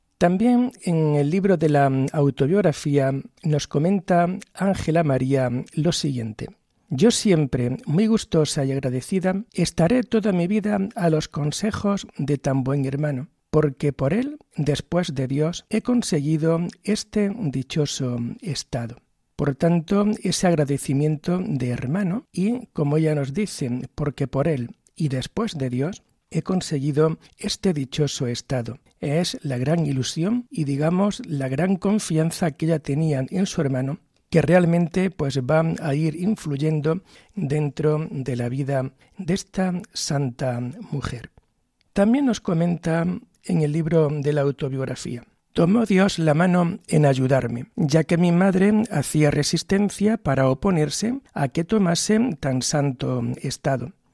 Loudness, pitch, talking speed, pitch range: -22 LUFS, 160 Hz, 135 wpm, 140-190 Hz